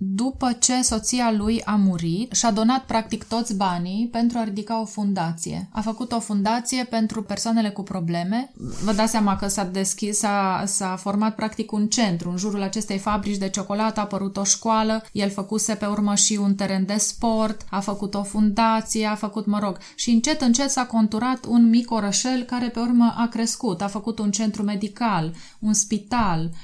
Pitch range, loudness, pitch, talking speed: 200-230 Hz, -22 LUFS, 215 Hz, 185 wpm